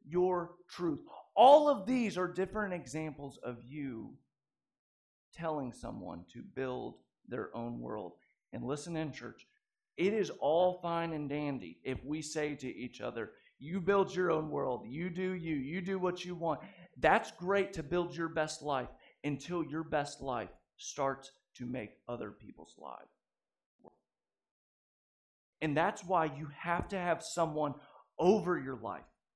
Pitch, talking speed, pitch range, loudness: 160 Hz, 155 wpm, 140-180 Hz, -35 LUFS